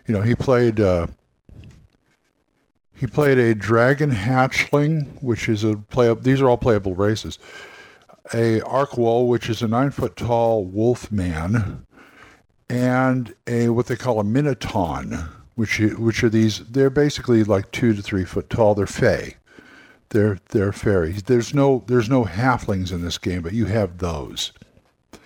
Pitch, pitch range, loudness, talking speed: 115 Hz, 105-125 Hz, -20 LUFS, 155 wpm